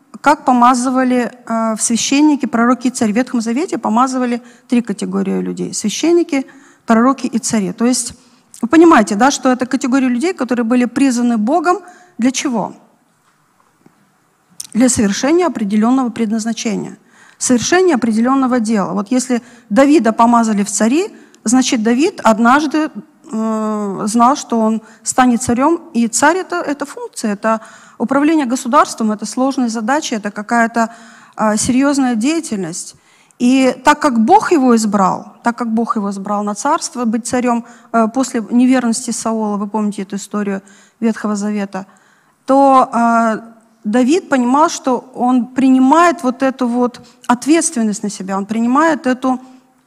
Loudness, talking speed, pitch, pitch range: -14 LUFS, 130 wpm, 245 Hz, 225-270 Hz